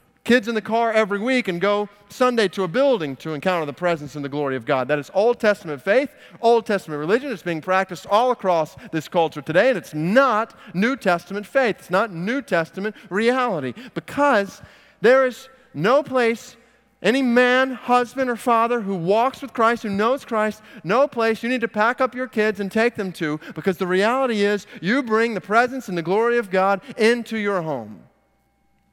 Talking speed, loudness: 195 wpm, -21 LUFS